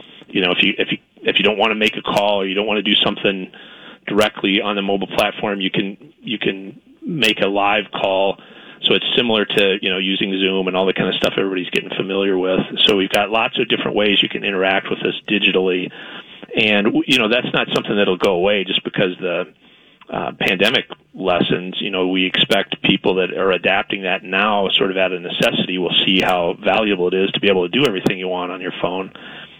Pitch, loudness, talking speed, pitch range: 95 Hz, -17 LUFS, 225 wpm, 95-100 Hz